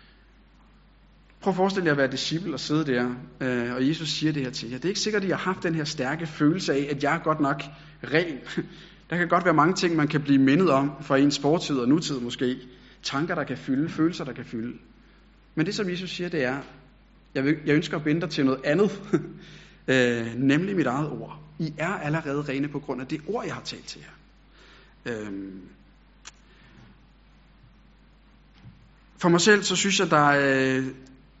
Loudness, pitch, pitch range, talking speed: -25 LUFS, 150 Hz, 135-170 Hz, 200 wpm